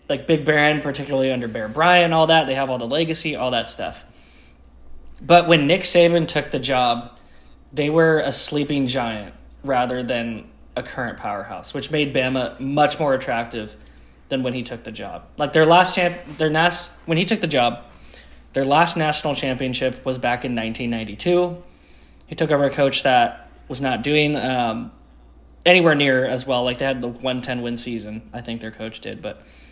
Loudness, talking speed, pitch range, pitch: -20 LUFS, 190 wpm, 115-155 Hz, 130 Hz